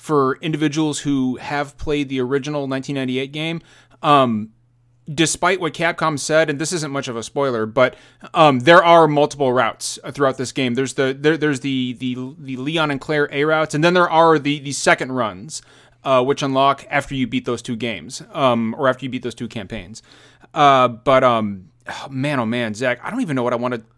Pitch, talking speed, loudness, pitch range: 140 Hz, 210 wpm, -18 LUFS, 125-150 Hz